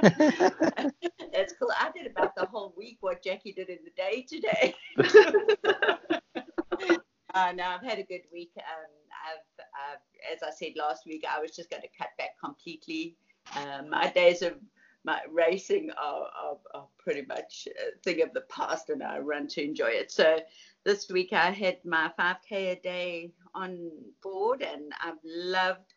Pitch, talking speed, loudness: 190 Hz, 175 wpm, -29 LUFS